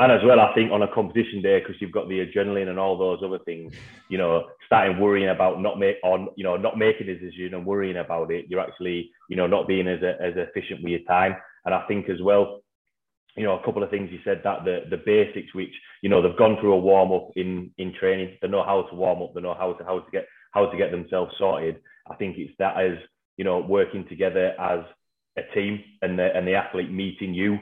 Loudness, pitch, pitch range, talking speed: -24 LUFS, 95 Hz, 90-100 Hz, 250 wpm